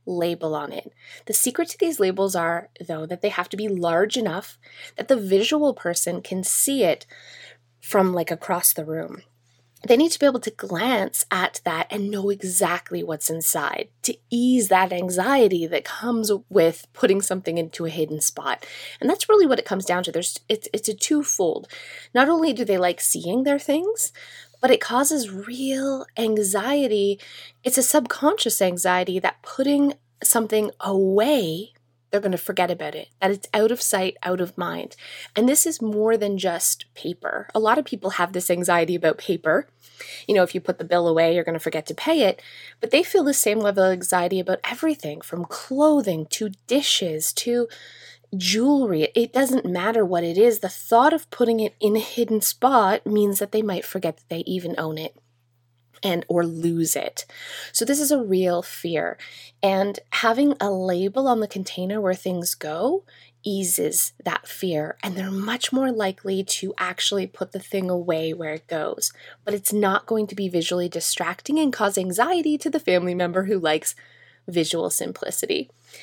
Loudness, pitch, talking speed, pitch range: -22 LUFS, 195 Hz, 185 wpm, 175-245 Hz